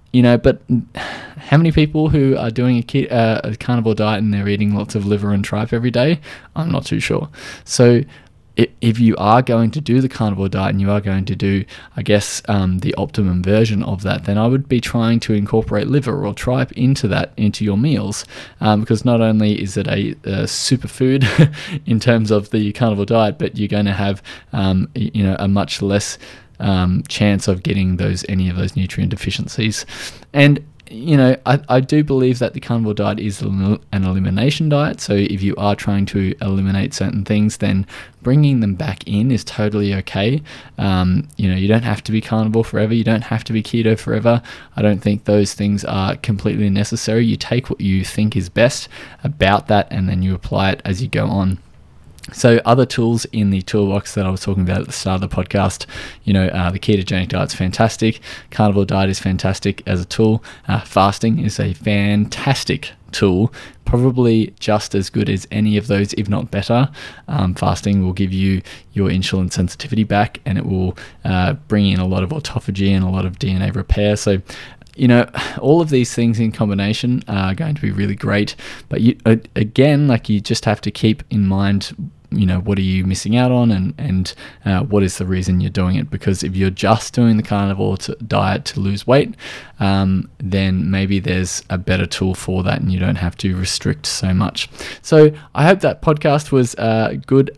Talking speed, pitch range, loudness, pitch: 205 wpm, 95-120 Hz, -17 LUFS, 105 Hz